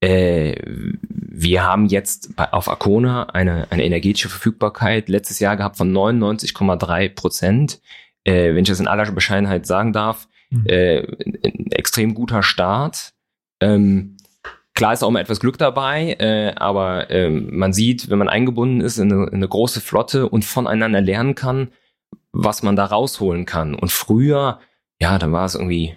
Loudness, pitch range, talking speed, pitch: -18 LUFS, 95-115 Hz, 160 wpm, 100 Hz